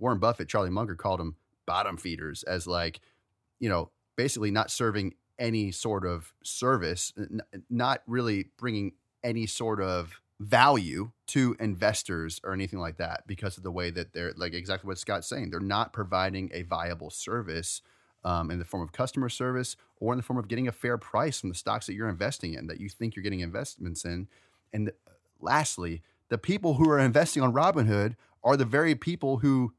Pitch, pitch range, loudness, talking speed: 100 Hz, 90-120 Hz, -30 LUFS, 190 wpm